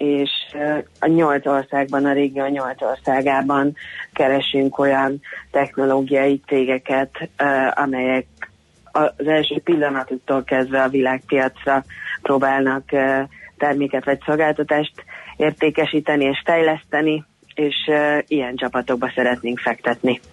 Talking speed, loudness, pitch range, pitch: 95 wpm, -19 LUFS, 130-145 Hz, 140 Hz